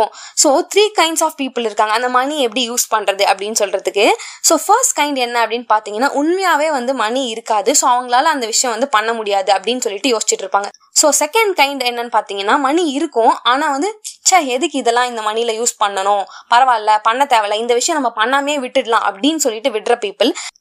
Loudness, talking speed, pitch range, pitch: -15 LUFS, 165 wpm, 215-290 Hz, 245 Hz